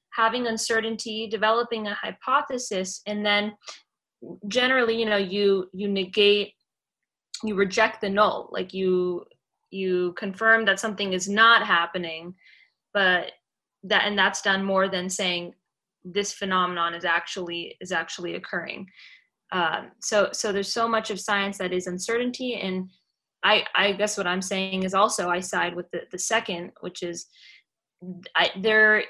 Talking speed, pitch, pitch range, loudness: 145 wpm, 200 Hz, 185-220 Hz, -24 LUFS